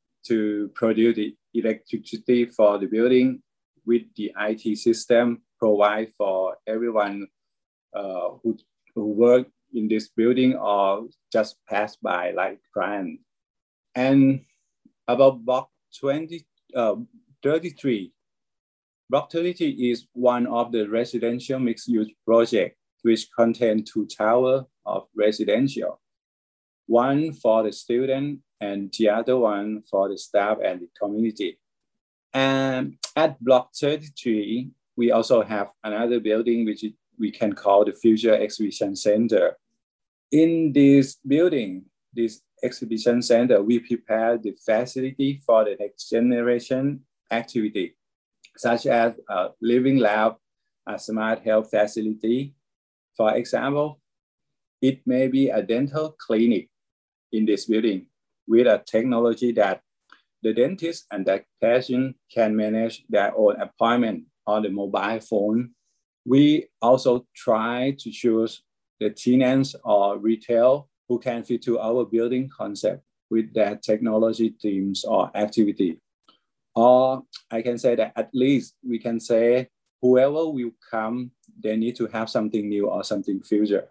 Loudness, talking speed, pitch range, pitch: -23 LUFS, 130 wpm, 110-130 Hz, 115 Hz